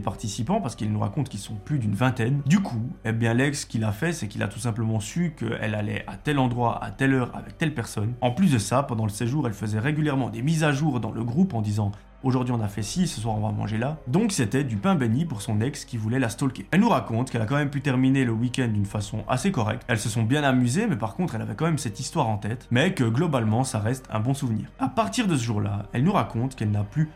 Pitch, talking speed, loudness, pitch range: 120 Hz, 285 wpm, -25 LUFS, 110-140 Hz